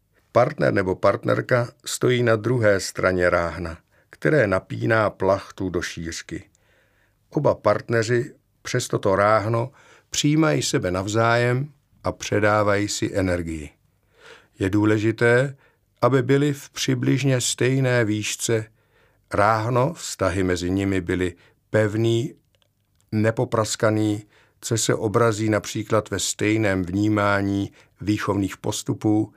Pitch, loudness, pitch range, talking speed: 110 Hz, -22 LUFS, 100-120 Hz, 100 wpm